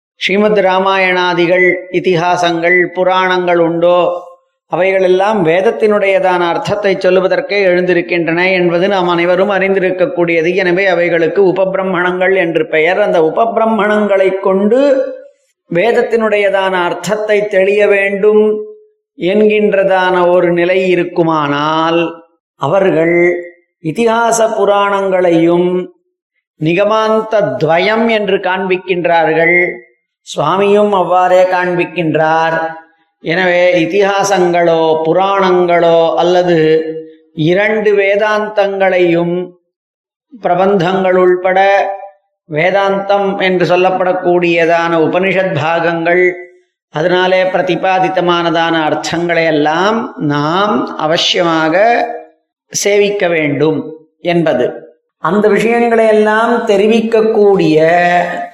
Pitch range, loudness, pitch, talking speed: 170-200 Hz, -11 LUFS, 180 Hz, 65 wpm